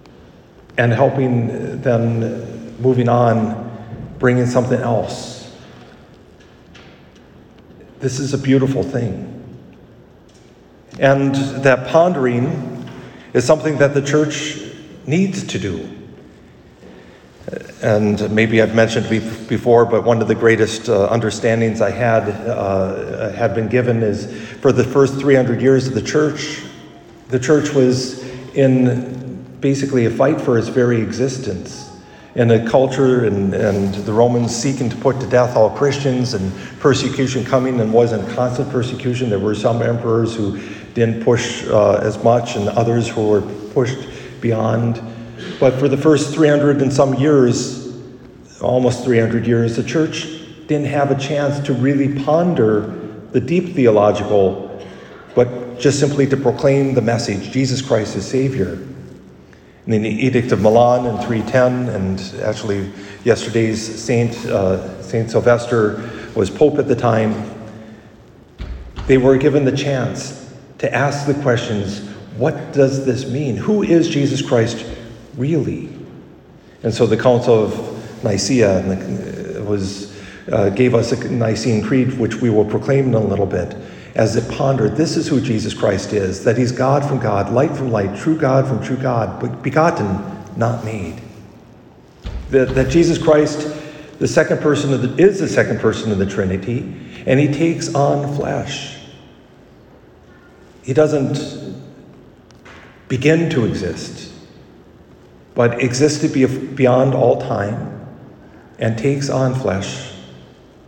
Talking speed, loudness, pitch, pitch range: 135 wpm, -17 LUFS, 125 Hz, 110-135 Hz